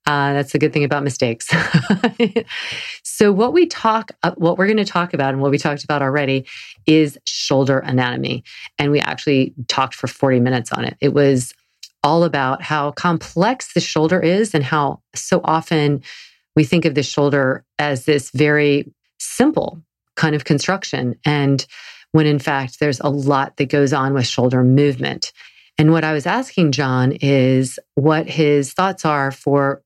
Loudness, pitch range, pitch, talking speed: -17 LUFS, 140-165 Hz, 145 Hz, 170 wpm